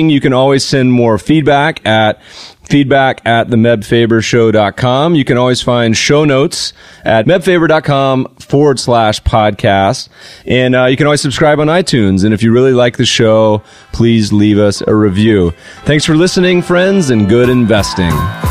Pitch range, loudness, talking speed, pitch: 110-145 Hz, -10 LUFS, 155 wpm, 125 Hz